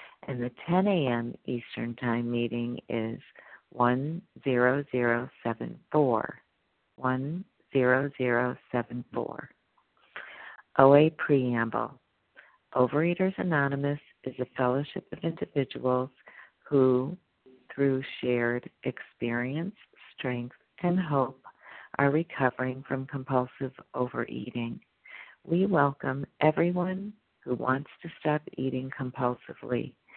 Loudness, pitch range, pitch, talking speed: -29 LUFS, 125-150 Hz, 130 Hz, 80 wpm